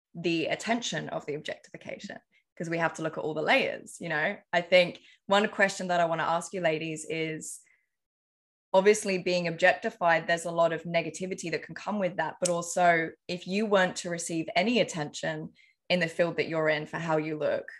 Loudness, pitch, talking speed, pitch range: -28 LUFS, 170 Hz, 200 wpm, 160-185 Hz